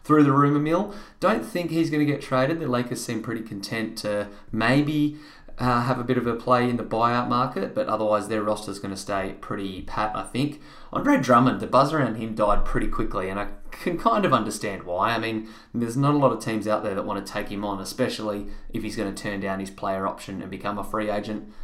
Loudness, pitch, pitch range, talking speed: -25 LUFS, 110 Hz, 105-130 Hz, 245 wpm